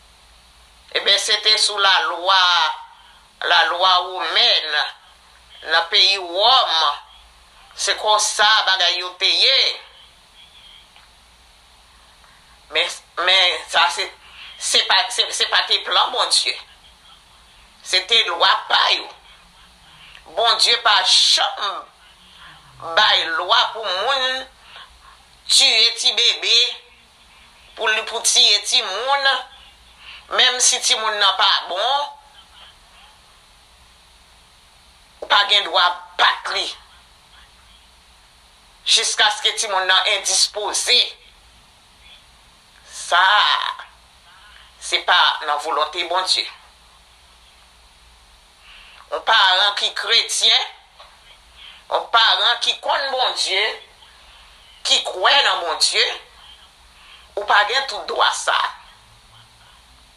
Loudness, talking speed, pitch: -16 LUFS, 95 wpm, 175 Hz